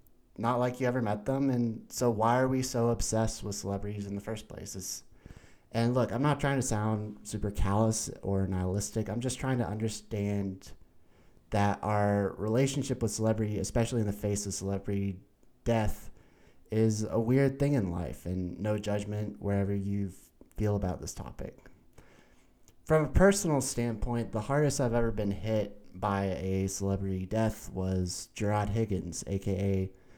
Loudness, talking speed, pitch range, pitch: -31 LUFS, 160 wpm, 100-115 Hz, 105 Hz